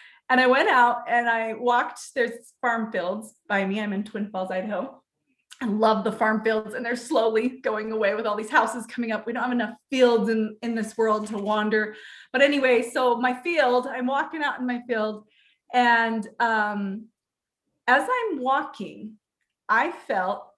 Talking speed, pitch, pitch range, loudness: 180 wpm, 230 Hz, 215-250 Hz, -24 LUFS